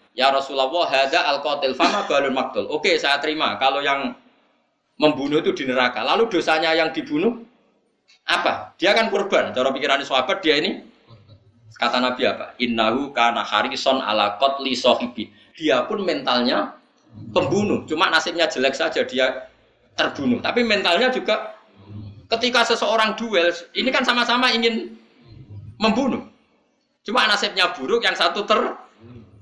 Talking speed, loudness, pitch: 135 wpm, -20 LUFS, 160 Hz